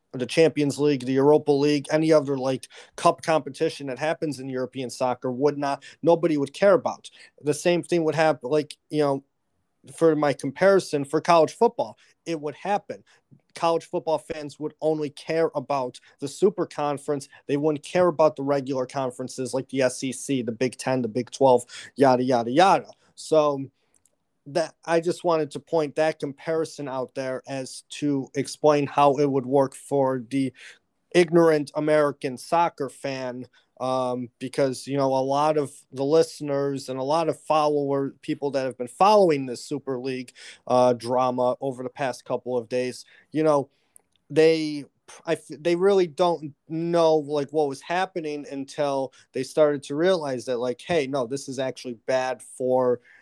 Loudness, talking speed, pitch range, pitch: -24 LUFS, 165 wpm, 130-155 Hz, 145 Hz